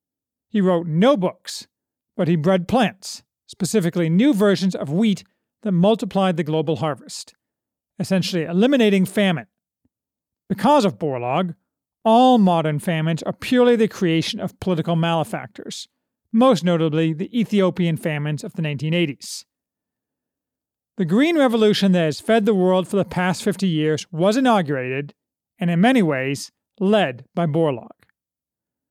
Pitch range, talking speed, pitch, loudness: 165-215 Hz, 135 wpm, 185 Hz, -19 LUFS